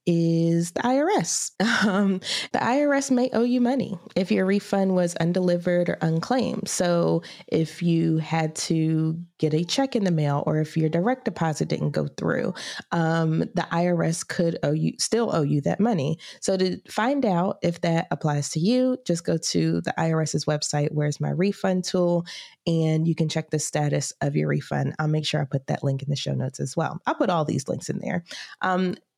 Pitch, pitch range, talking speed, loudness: 165 Hz, 155-190 Hz, 195 wpm, -24 LUFS